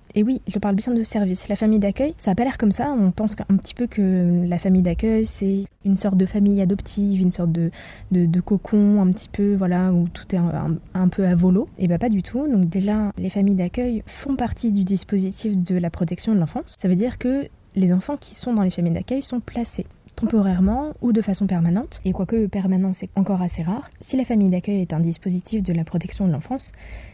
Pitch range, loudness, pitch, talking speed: 185-220 Hz, -21 LUFS, 195 Hz, 235 wpm